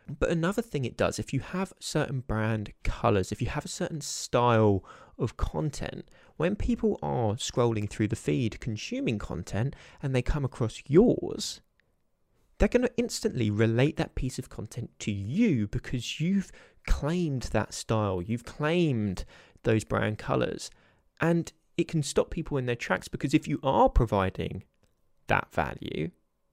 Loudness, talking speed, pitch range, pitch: -29 LUFS, 155 wpm, 110-155 Hz, 125 Hz